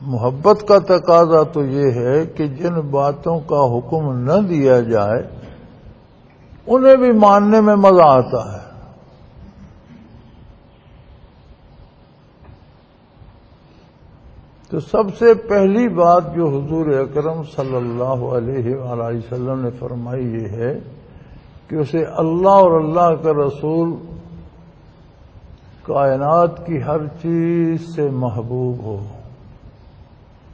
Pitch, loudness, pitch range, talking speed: 145 Hz, -16 LUFS, 125-170 Hz, 100 wpm